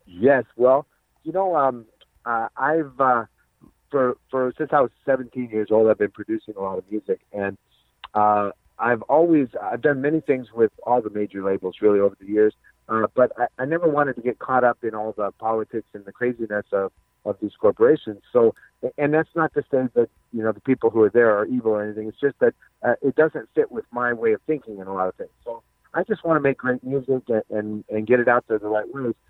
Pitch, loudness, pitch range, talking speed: 120 Hz, -22 LUFS, 105-140 Hz, 235 wpm